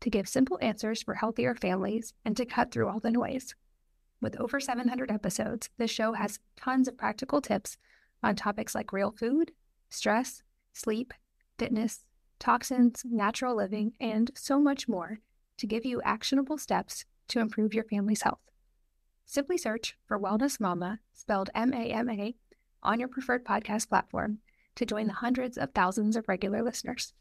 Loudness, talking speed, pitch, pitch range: -31 LUFS, 155 wpm, 230 Hz, 215-250 Hz